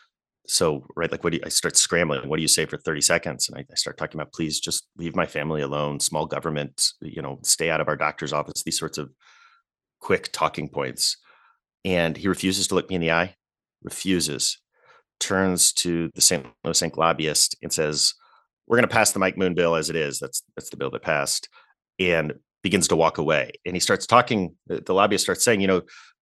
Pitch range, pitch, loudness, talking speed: 75-95 Hz, 85 Hz, -23 LUFS, 220 wpm